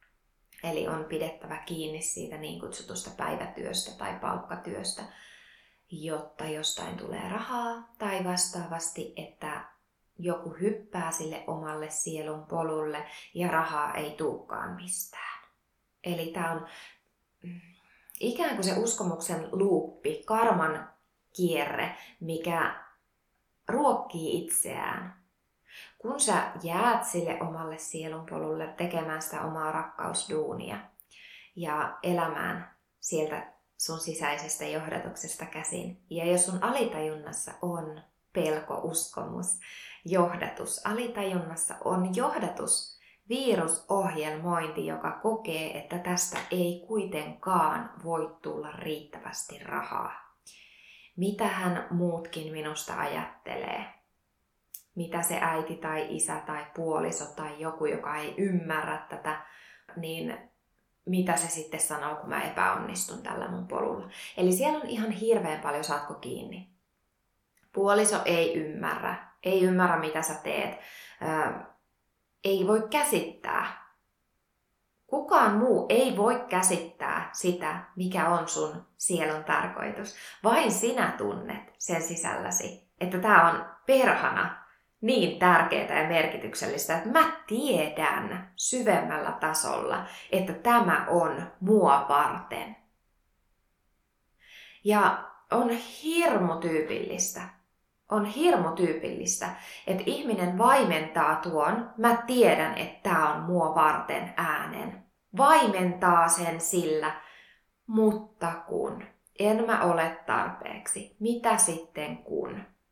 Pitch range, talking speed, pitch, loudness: 155-200 Hz, 105 wpm, 170 Hz, -29 LUFS